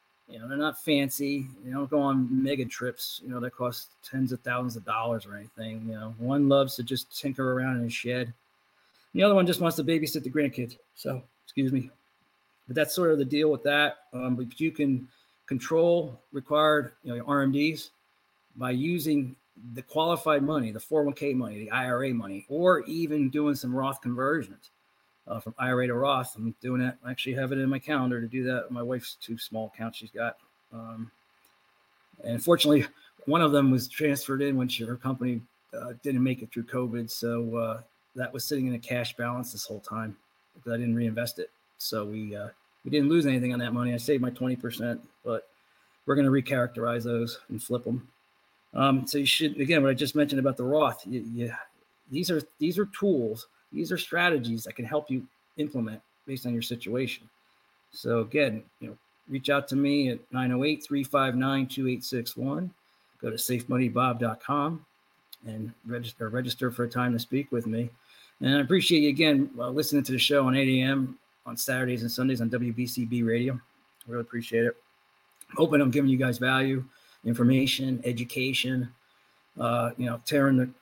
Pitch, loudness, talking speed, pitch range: 130 Hz, -28 LUFS, 190 wpm, 120-140 Hz